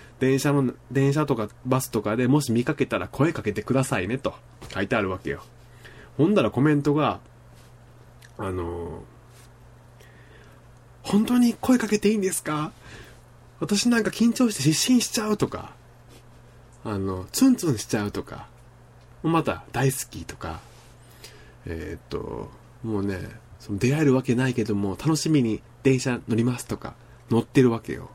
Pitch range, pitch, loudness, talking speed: 115-140 Hz, 120 Hz, -24 LUFS, 290 characters per minute